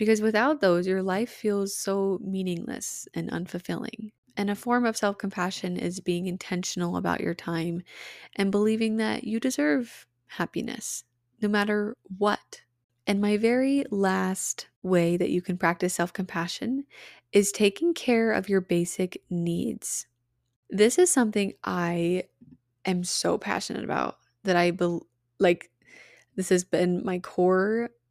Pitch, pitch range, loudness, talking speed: 190 Hz, 175-215 Hz, -27 LUFS, 135 wpm